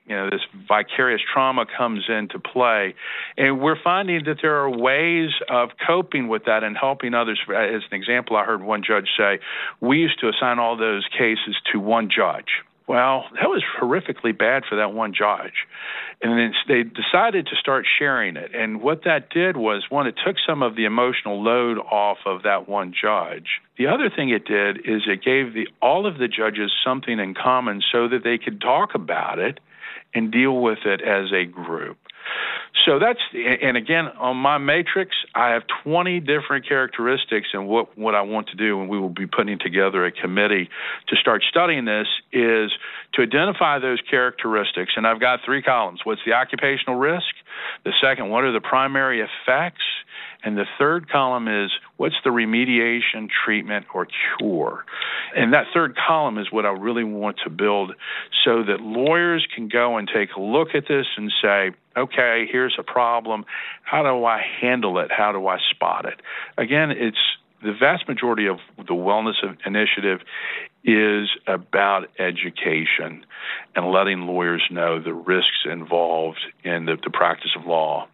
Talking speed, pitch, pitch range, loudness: 175 wpm, 115 Hz, 105-130 Hz, -21 LUFS